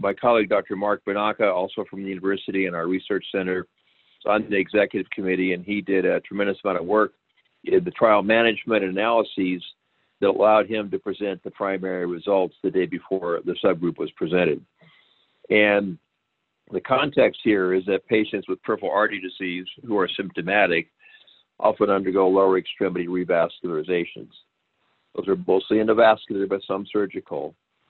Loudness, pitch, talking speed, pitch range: -23 LUFS, 95 Hz, 155 wpm, 95-105 Hz